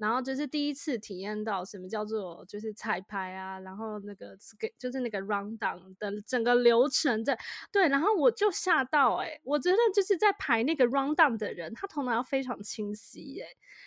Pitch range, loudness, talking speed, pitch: 210-290 Hz, -29 LUFS, 365 characters per minute, 235 Hz